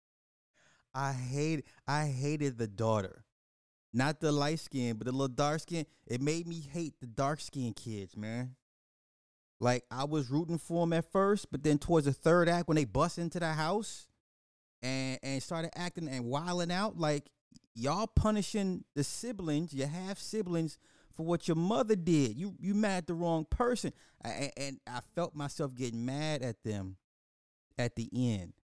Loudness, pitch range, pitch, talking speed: -34 LUFS, 125-170 Hz, 145 Hz, 175 wpm